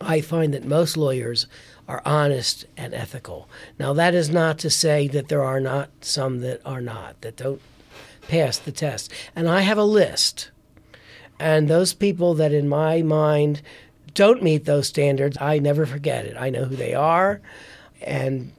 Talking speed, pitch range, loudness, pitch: 175 wpm, 130-155 Hz, -21 LUFS, 145 Hz